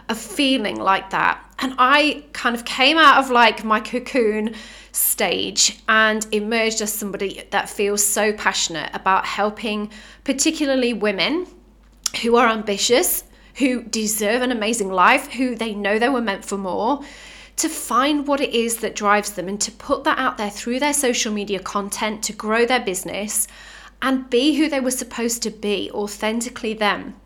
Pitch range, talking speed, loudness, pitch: 210-255 Hz, 165 wpm, -19 LUFS, 225 Hz